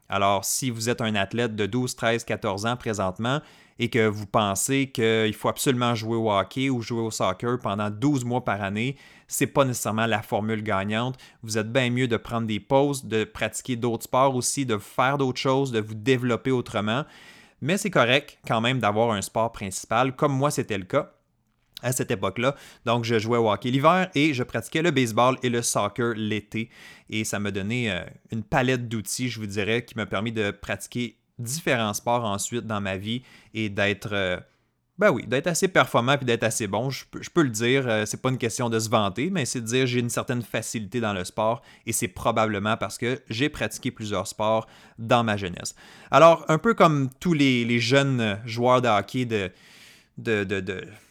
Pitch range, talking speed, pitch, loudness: 110-130 Hz, 205 wpm, 120 Hz, -25 LUFS